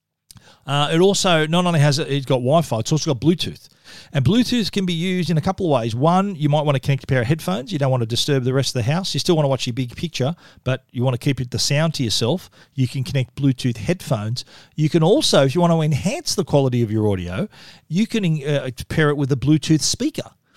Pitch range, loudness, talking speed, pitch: 130-170 Hz, -20 LUFS, 260 wpm, 145 Hz